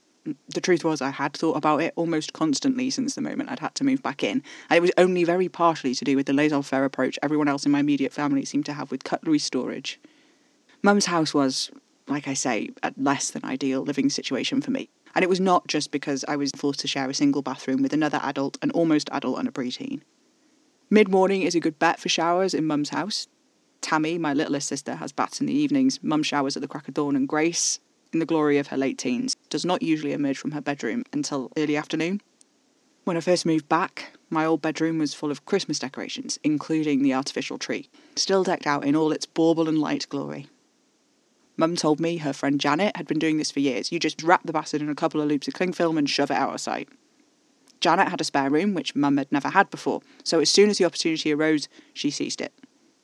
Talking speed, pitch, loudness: 235 wpm, 160 Hz, -24 LUFS